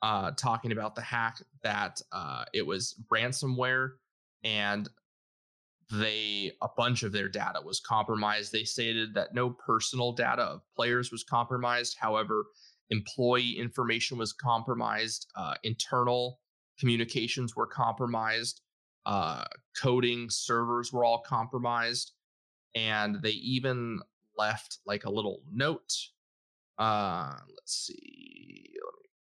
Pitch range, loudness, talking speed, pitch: 110-125 Hz, -31 LUFS, 115 wpm, 120 Hz